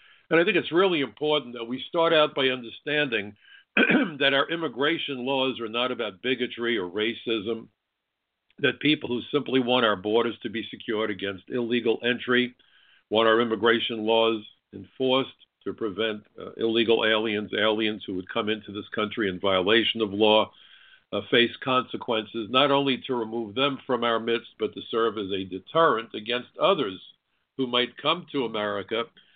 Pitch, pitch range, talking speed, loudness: 120 Hz, 110-135 Hz, 165 wpm, -25 LUFS